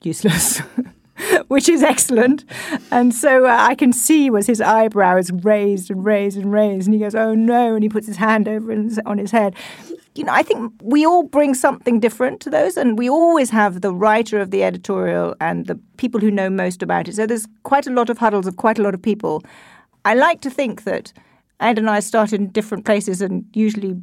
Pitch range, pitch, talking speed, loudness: 205-250 Hz, 220 Hz, 220 wpm, -17 LUFS